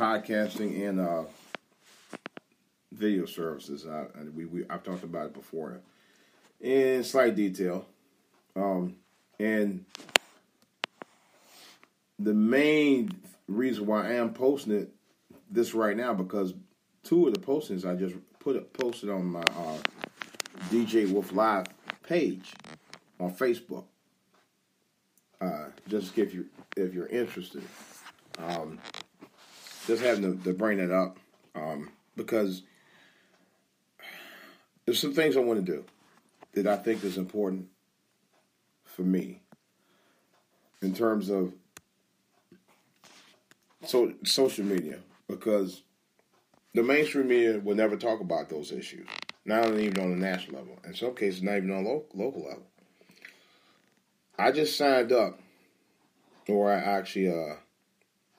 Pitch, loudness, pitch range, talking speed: 100 Hz, -29 LUFS, 95-115 Hz, 120 wpm